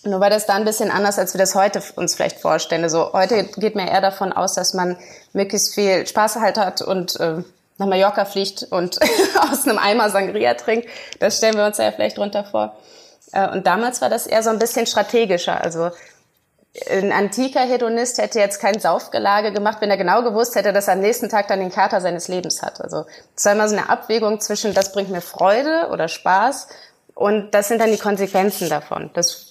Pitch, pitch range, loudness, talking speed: 200 Hz, 190-220 Hz, -18 LUFS, 210 wpm